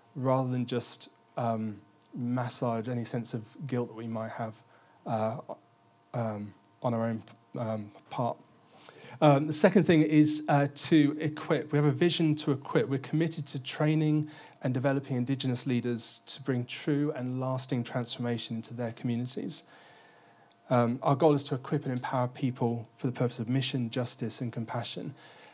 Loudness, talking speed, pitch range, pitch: -30 LUFS, 160 wpm, 115-145 Hz, 125 Hz